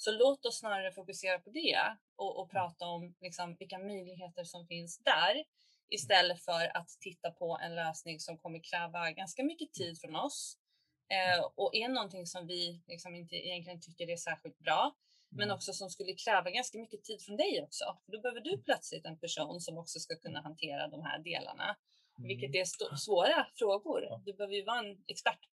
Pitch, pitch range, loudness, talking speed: 180 Hz, 170-205 Hz, -36 LUFS, 195 wpm